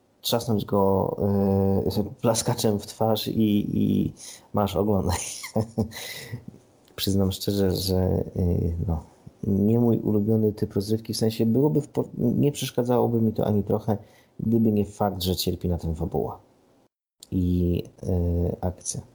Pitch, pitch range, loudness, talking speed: 105 Hz, 95-115 Hz, -25 LUFS, 125 wpm